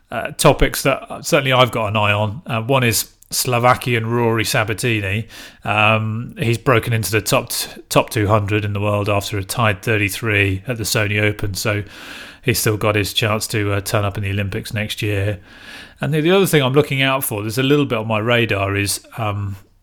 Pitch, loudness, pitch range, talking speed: 110 Hz, -18 LUFS, 105-120 Hz, 205 wpm